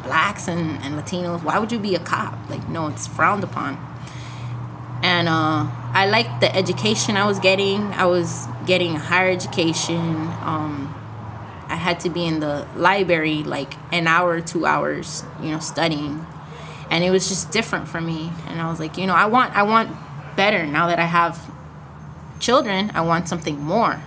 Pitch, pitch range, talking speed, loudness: 165 Hz, 150-180 Hz, 180 wpm, -20 LUFS